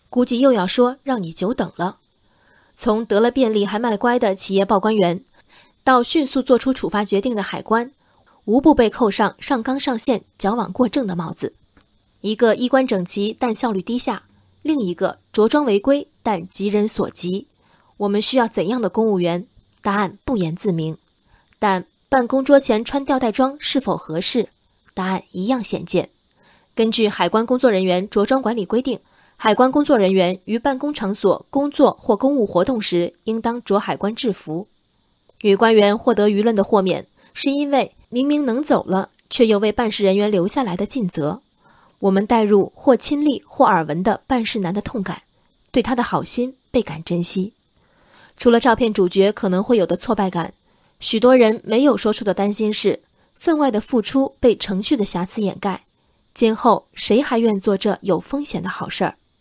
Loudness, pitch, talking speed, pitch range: -19 LUFS, 215 Hz, 260 characters per minute, 195-250 Hz